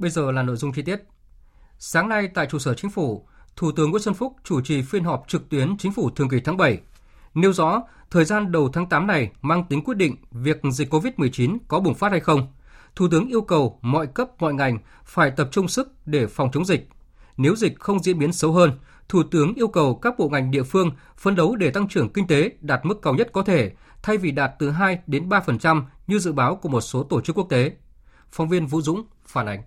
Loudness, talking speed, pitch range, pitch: -22 LUFS, 240 wpm, 135-190 Hz, 155 Hz